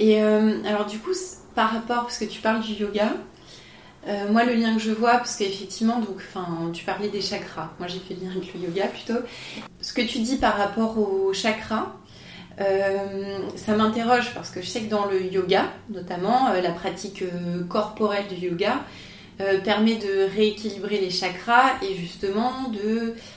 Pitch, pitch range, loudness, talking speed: 205 Hz, 190-225 Hz, -24 LUFS, 185 wpm